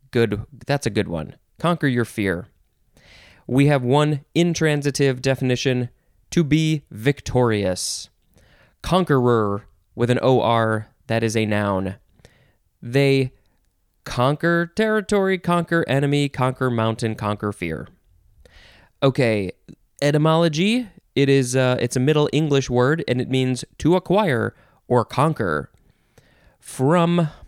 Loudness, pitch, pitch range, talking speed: -21 LUFS, 130 Hz, 110-150 Hz, 115 wpm